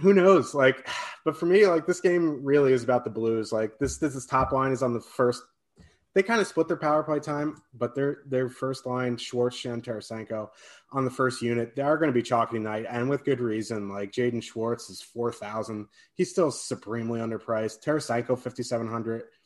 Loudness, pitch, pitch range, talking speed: -27 LUFS, 125 Hz, 115-145 Hz, 215 wpm